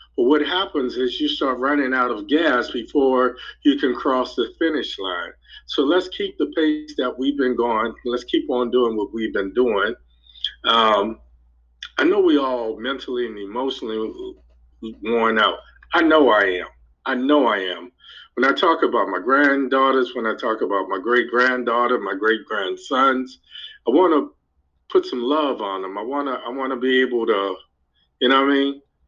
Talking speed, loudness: 180 wpm, -20 LUFS